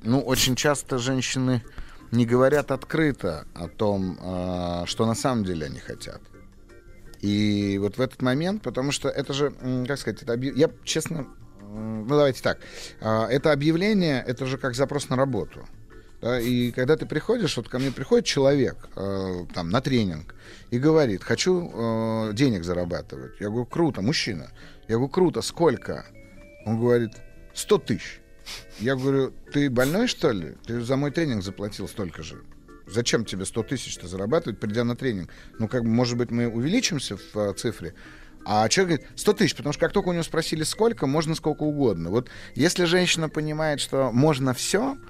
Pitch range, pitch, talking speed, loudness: 105-145 Hz, 125 Hz, 165 wpm, -25 LUFS